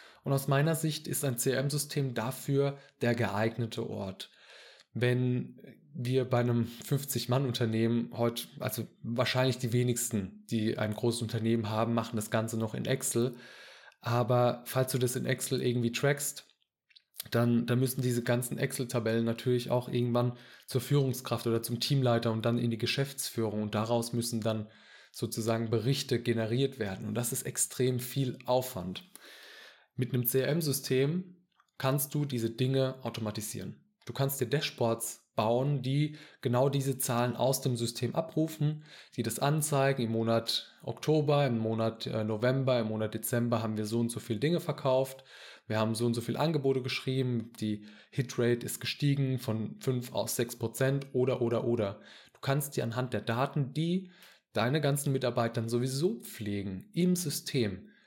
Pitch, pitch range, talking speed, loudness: 125 Hz, 115-135 Hz, 155 wpm, -31 LUFS